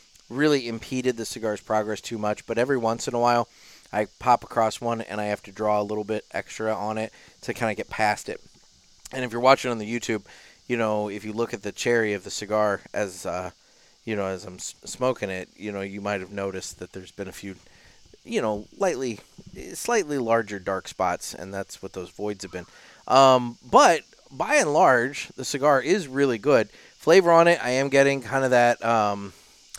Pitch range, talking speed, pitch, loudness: 100-120 Hz, 210 wpm, 110 Hz, -24 LUFS